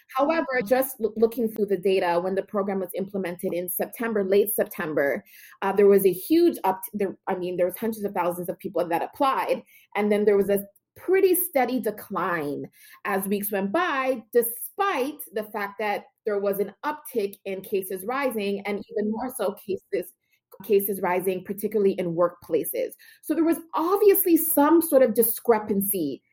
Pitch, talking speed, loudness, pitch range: 210 Hz, 165 wpm, -25 LUFS, 195-265 Hz